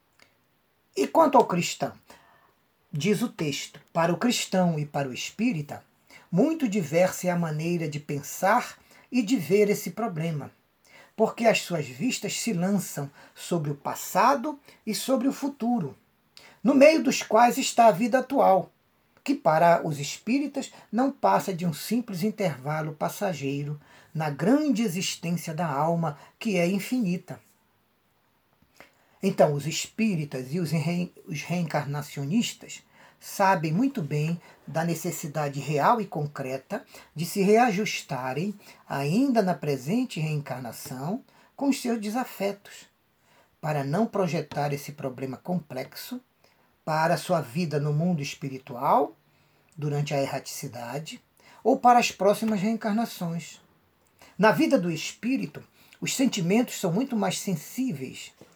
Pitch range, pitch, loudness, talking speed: 150-225 Hz, 180 Hz, -26 LUFS, 125 wpm